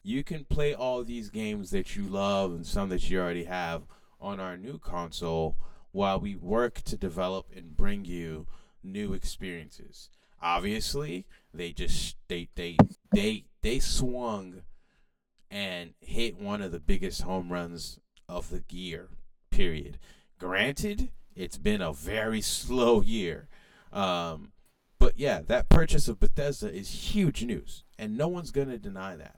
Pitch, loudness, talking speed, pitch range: 100 Hz, -31 LUFS, 150 wpm, 85-120 Hz